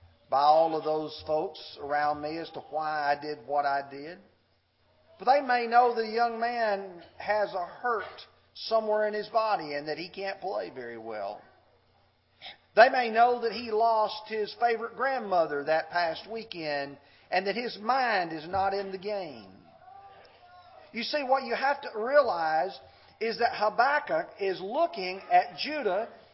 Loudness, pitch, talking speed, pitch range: -28 LUFS, 200 Hz, 160 wpm, 155-235 Hz